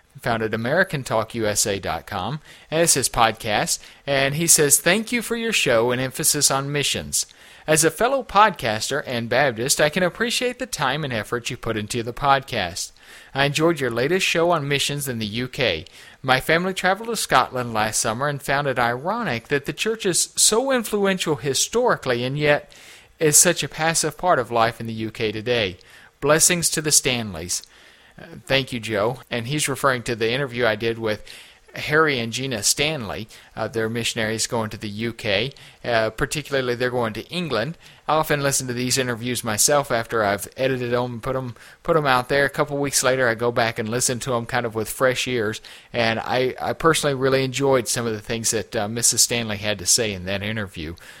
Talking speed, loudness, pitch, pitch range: 195 wpm, -21 LUFS, 130 Hz, 115-150 Hz